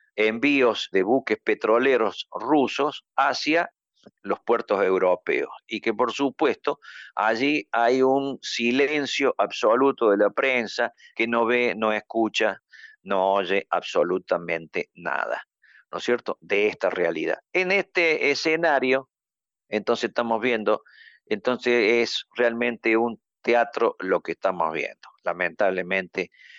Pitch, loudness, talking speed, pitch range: 120 Hz, -24 LUFS, 115 wpm, 110-135 Hz